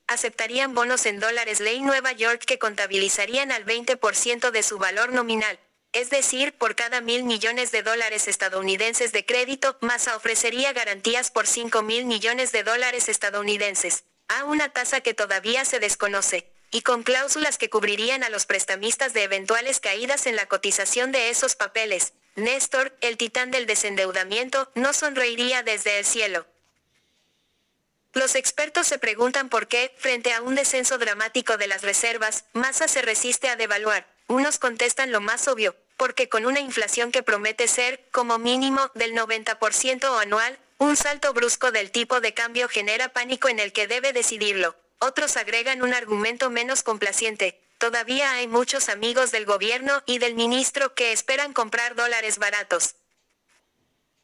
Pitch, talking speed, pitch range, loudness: 235 Hz, 155 wpm, 215-260 Hz, -22 LUFS